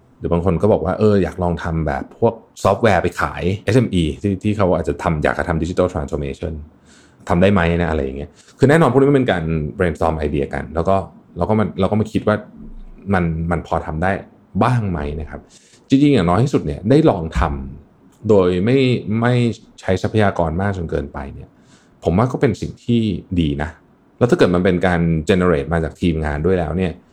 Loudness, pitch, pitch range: -18 LUFS, 90 Hz, 80-100 Hz